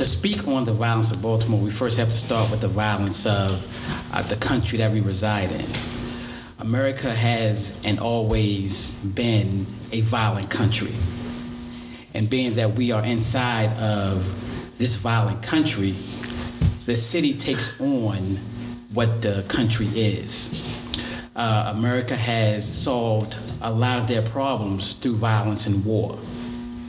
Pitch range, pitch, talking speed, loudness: 105-120 Hz, 115 Hz, 140 wpm, -23 LUFS